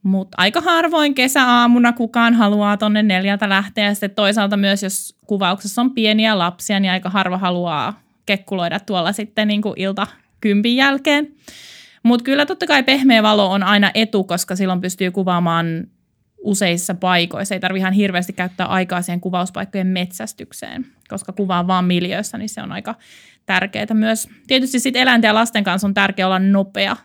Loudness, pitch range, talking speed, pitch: -17 LUFS, 185-225 Hz, 160 wpm, 205 Hz